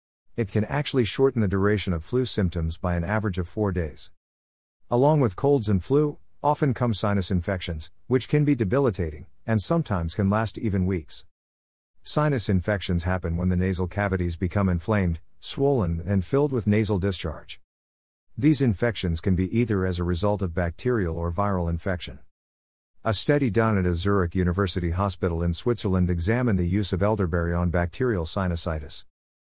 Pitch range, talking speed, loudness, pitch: 85-110 Hz, 165 wpm, -25 LUFS, 95 Hz